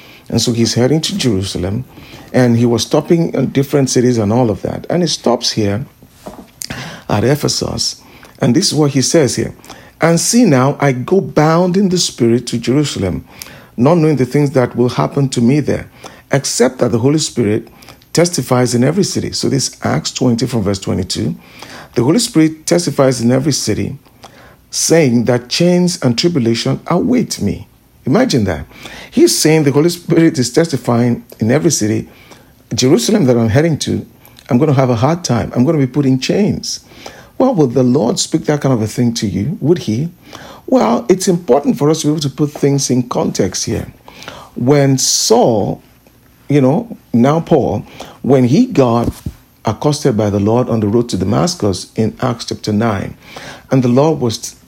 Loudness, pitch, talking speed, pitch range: -14 LUFS, 130 Hz, 185 wpm, 120-155 Hz